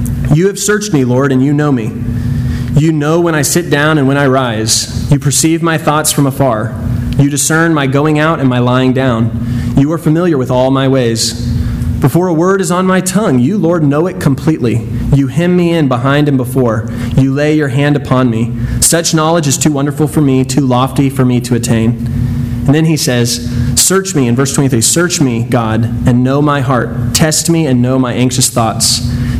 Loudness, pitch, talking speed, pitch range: -11 LUFS, 135 Hz, 210 wpm, 120-155 Hz